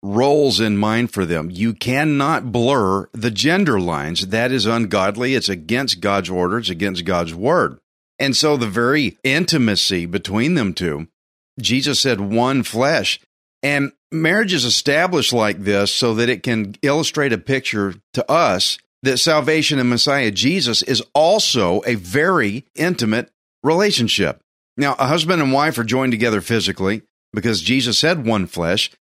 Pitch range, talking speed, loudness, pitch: 100-135 Hz, 155 wpm, -17 LUFS, 120 Hz